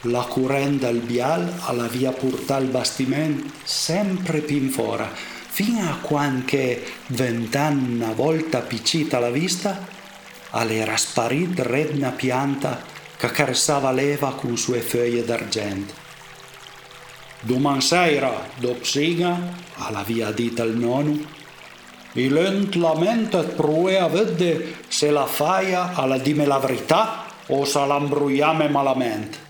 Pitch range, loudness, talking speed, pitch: 125-160 Hz, -22 LUFS, 110 wpm, 140 Hz